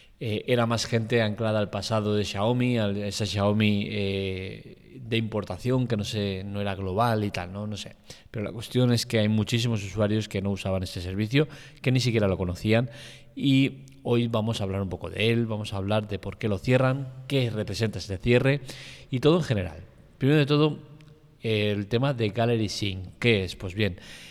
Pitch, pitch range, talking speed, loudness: 110 Hz, 100-125 Hz, 195 wpm, -26 LUFS